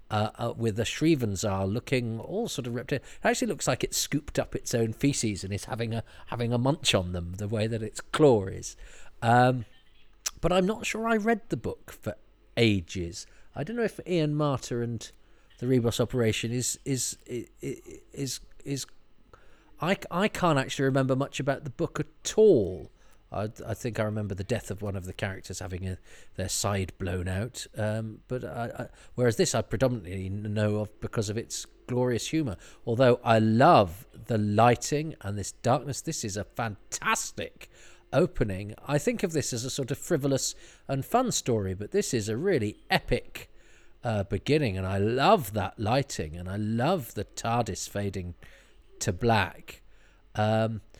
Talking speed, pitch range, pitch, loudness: 180 wpm, 105-135 Hz, 115 Hz, -28 LUFS